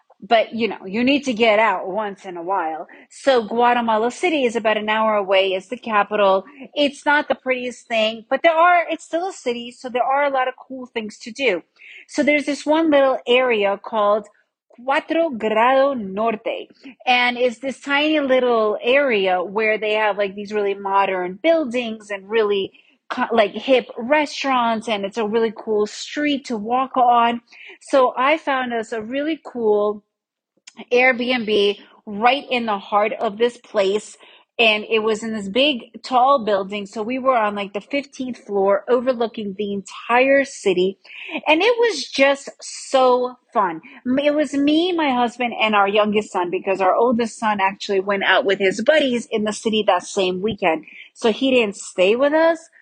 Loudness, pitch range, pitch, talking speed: -19 LUFS, 210-270 Hz, 235 Hz, 175 wpm